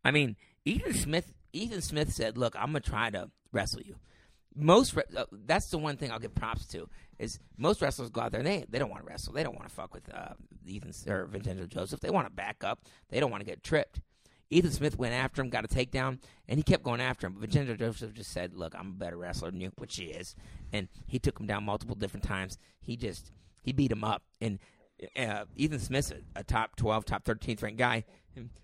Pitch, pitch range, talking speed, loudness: 110 Hz, 95-125 Hz, 240 wpm, -33 LUFS